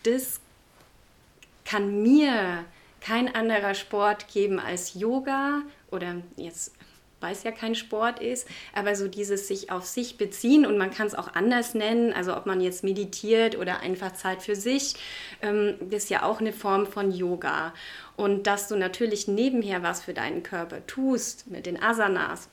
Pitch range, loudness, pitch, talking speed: 195-230 Hz, -27 LUFS, 210 Hz, 165 wpm